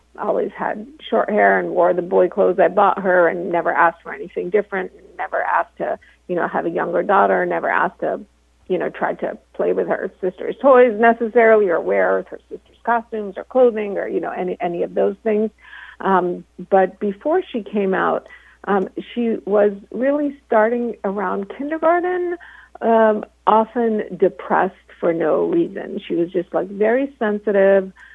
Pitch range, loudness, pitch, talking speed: 190-245 Hz, -19 LUFS, 215 Hz, 175 wpm